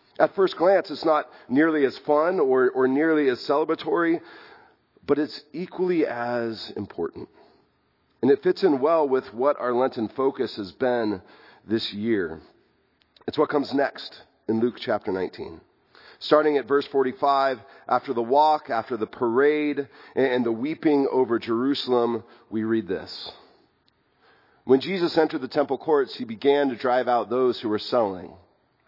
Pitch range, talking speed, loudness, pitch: 120-160 Hz, 150 wpm, -24 LUFS, 135 Hz